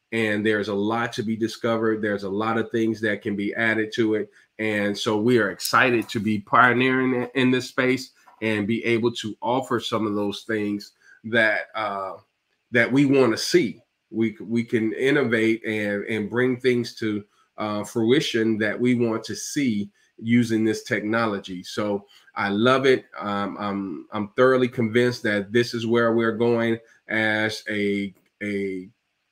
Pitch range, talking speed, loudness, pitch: 105-120 Hz, 170 wpm, -23 LUFS, 110 Hz